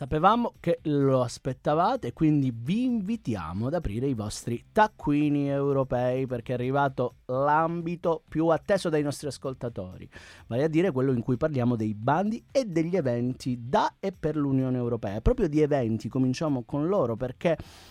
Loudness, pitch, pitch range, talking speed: -27 LUFS, 135 Hz, 120-160 Hz, 160 wpm